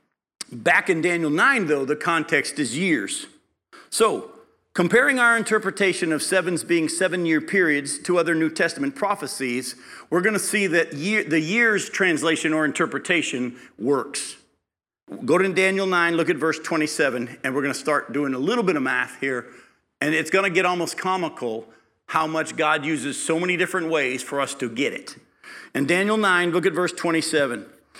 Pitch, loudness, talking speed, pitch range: 165 Hz, -22 LUFS, 180 wpm, 150-185 Hz